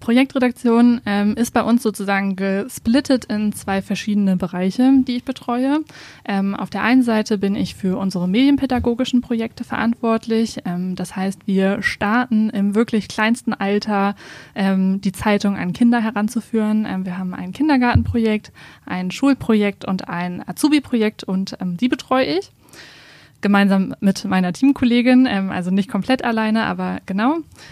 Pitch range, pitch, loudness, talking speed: 195-245 Hz, 215 Hz, -19 LUFS, 145 wpm